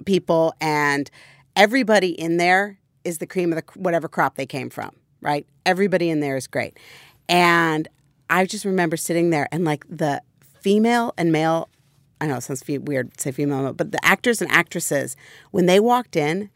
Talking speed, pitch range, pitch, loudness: 190 wpm, 145-185 Hz, 165 Hz, -21 LUFS